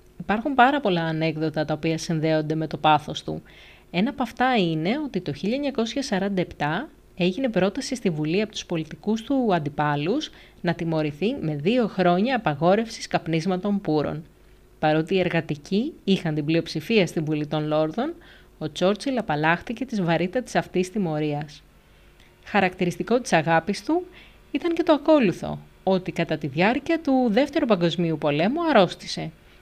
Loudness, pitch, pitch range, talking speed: -24 LUFS, 180 Hz, 160-230 Hz, 140 wpm